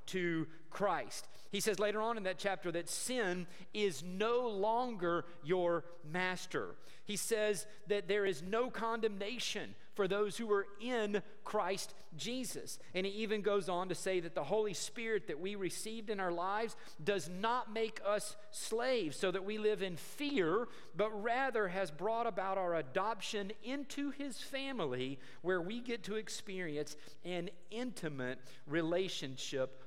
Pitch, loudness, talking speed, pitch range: 200 Hz, -38 LUFS, 155 wpm, 175-220 Hz